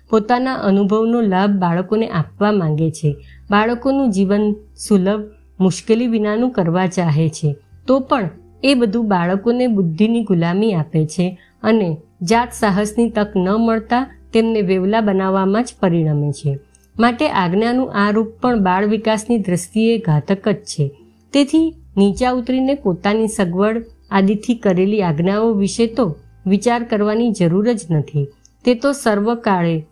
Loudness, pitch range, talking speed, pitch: -17 LUFS, 180-230 Hz, 130 wpm, 210 Hz